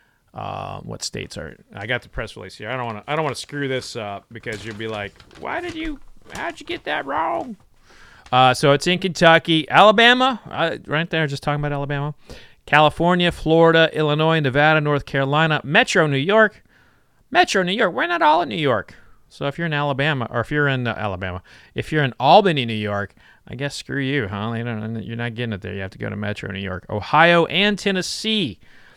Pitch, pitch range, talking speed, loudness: 145 Hz, 115-165 Hz, 215 wpm, -19 LUFS